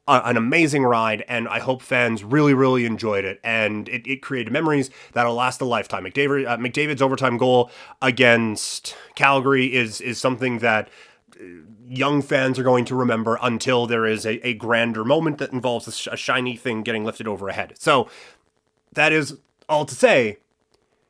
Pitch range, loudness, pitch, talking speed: 115-135 Hz, -20 LUFS, 125 Hz, 175 wpm